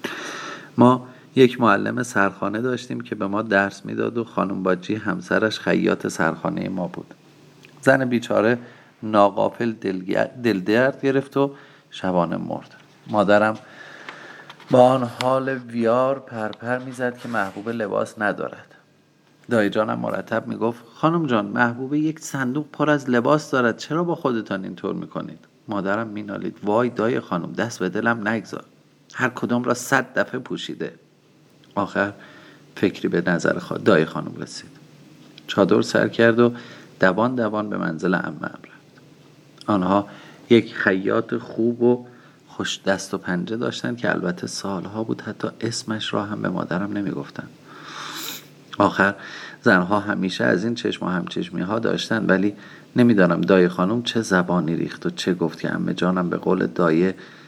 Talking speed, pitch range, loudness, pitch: 145 wpm, 100-130 Hz, -22 LUFS, 115 Hz